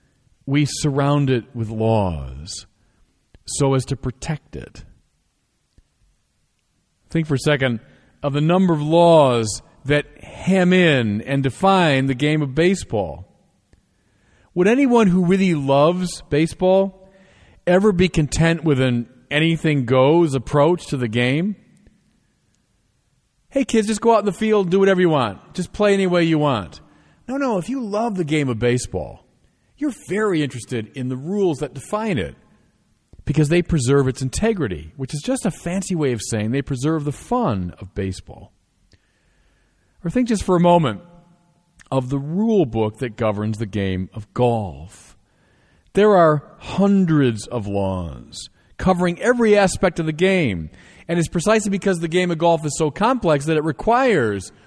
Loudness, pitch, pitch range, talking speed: -19 LUFS, 150 Hz, 120-185 Hz, 155 wpm